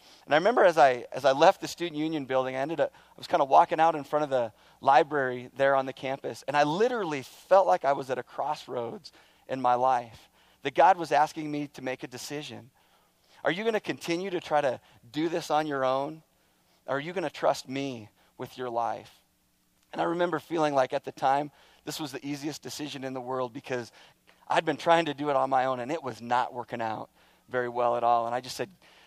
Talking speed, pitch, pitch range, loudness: 235 wpm, 135 Hz, 125-155 Hz, -28 LUFS